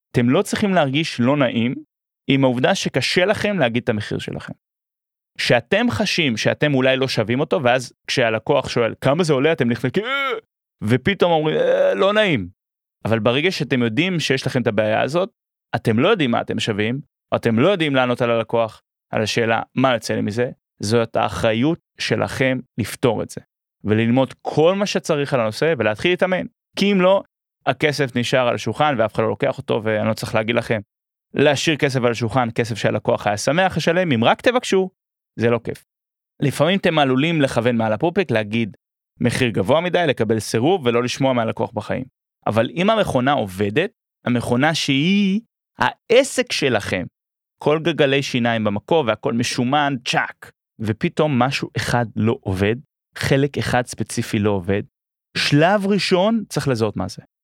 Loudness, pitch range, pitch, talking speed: -19 LUFS, 115-165 Hz, 130 Hz, 165 wpm